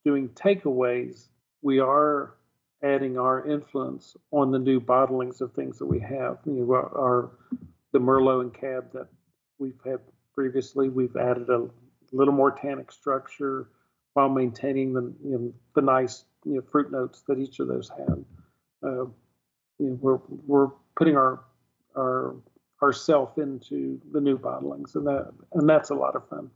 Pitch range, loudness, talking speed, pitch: 125-140 Hz, -26 LUFS, 160 wpm, 130 Hz